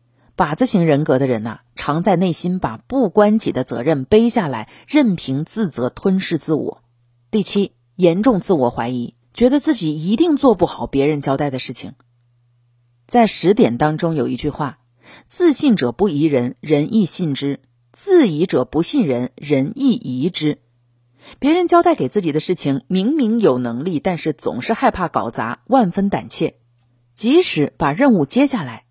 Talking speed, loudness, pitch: 245 characters per minute, -17 LUFS, 155 Hz